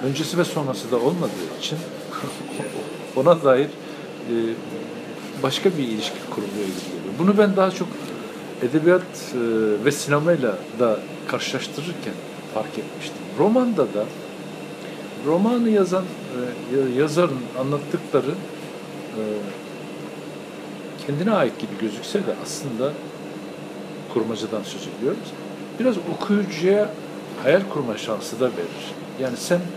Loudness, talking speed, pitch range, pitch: -23 LUFS, 105 wpm, 125-185 Hz, 155 Hz